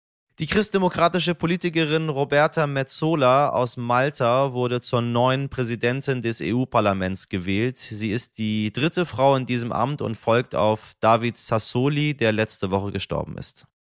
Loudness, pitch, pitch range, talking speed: -22 LUFS, 125 Hz, 110-145 Hz, 135 wpm